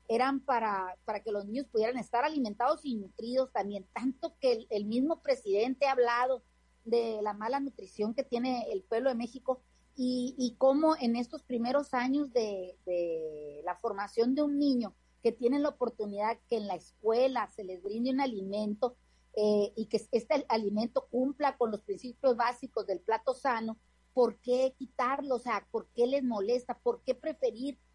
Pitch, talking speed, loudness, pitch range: 240 Hz, 175 wpm, -32 LUFS, 215-260 Hz